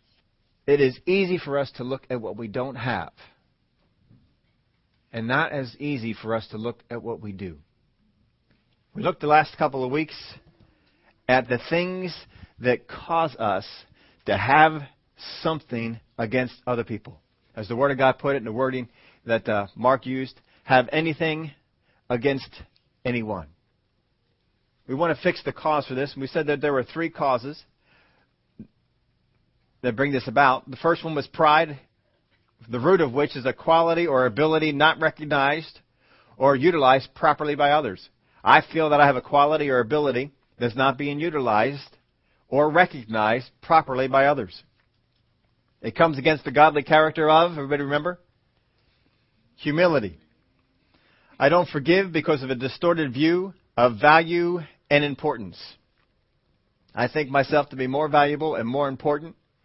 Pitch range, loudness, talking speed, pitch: 125-155 Hz, -23 LUFS, 155 wpm, 140 Hz